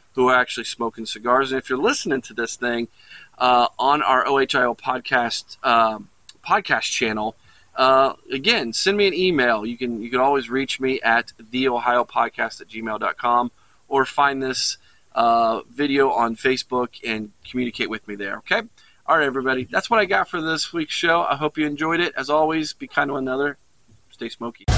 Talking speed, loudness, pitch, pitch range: 180 wpm, -21 LUFS, 130 Hz, 115-140 Hz